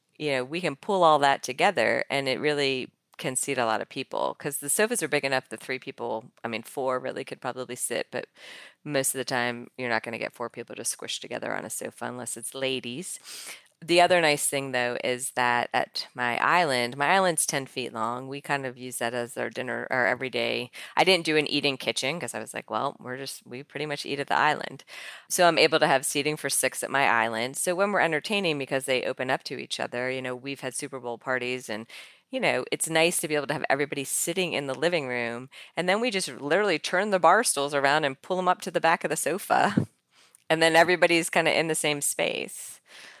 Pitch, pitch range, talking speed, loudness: 140 Hz, 125-160 Hz, 240 wpm, -26 LUFS